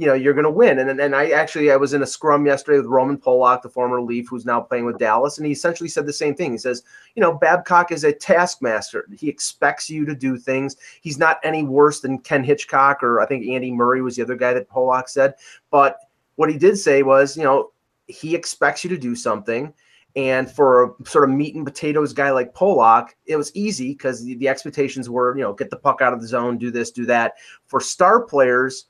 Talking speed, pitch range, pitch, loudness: 240 wpm, 125-150 Hz, 135 Hz, -18 LUFS